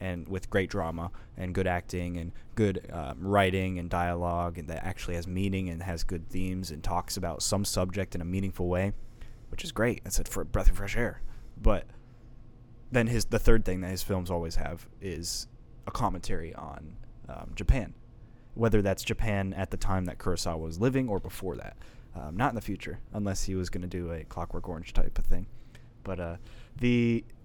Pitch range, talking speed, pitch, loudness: 90-115 Hz, 200 wpm, 95 Hz, -32 LUFS